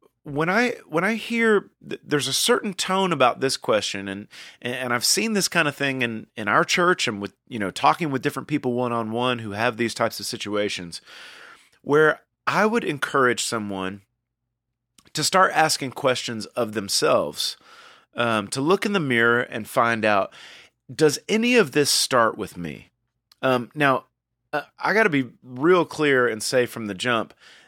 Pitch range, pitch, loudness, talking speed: 115-155 Hz, 125 Hz, -22 LUFS, 180 wpm